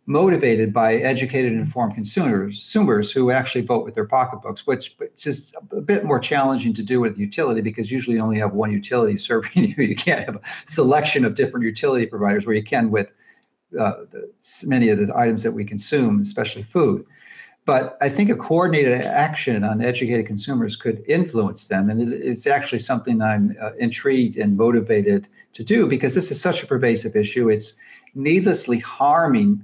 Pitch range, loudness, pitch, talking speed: 110-185 Hz, -20 LUFS, 125 Hz, 185 wpm